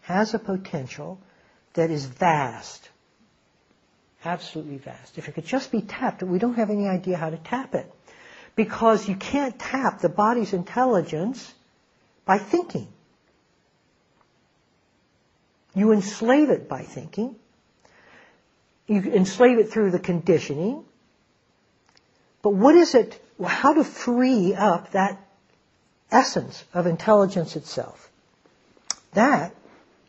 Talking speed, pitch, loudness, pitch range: 115 wpm, 205 Hz, -23 LUFS, 175-240 Hz